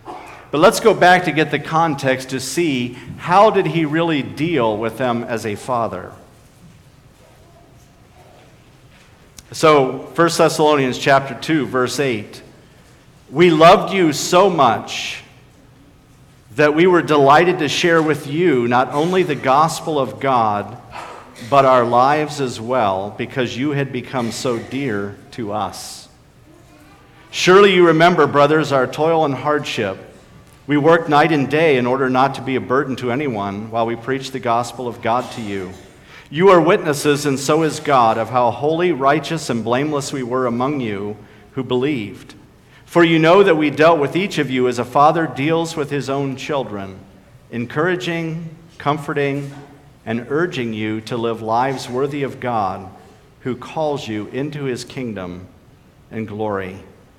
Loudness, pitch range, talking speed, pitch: -17 LUFS, 120-155 Hz, 155 wpm, 135 Hz